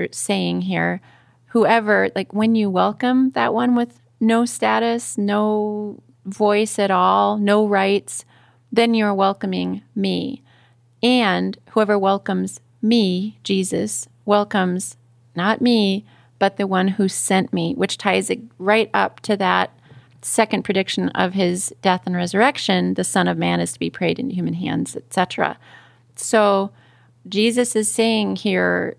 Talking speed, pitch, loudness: 140 wpm, 195 Hz, -19 LUFS